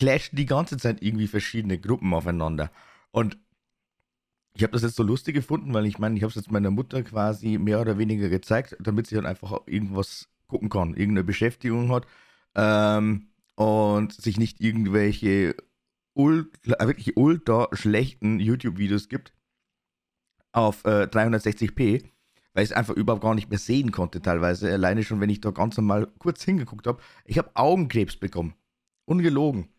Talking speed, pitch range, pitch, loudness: 160 wpm, 100-120 Hz, 110 Hz, -25 LUFS